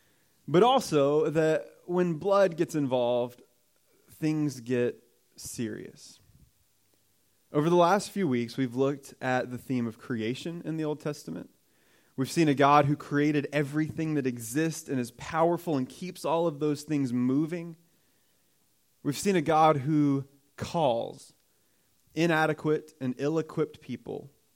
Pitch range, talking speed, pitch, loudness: 130-160 Hz, 135 wpm, 150 Hz, -28 LUFS